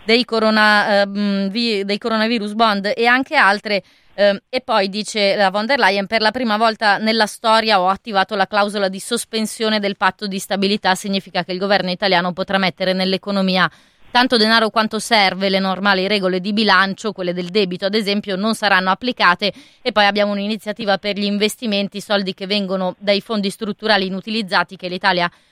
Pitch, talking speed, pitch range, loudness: 205 Hz, 175 wpm, 190-220 Hz, -17 LUFS